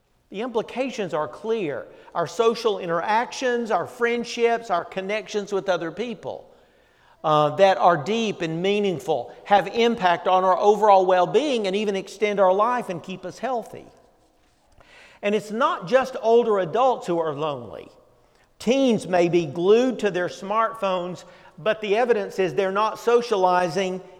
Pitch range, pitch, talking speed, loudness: 185-230 Hz, 205 Hz, 145 wpm, -22 LUFS